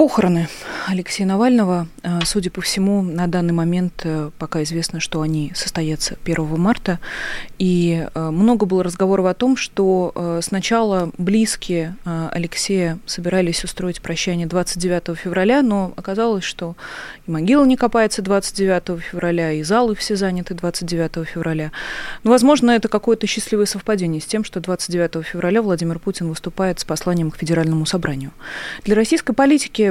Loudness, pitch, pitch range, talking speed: -19 LUFS, 180 Hz, 170-205 Hz, 135 wpm